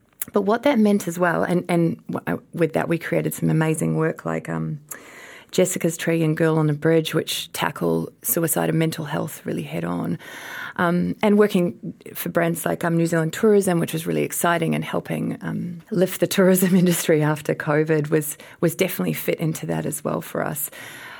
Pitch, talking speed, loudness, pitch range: 170 Hz, 185 wpm, -22 LUFS, 155-180 Hz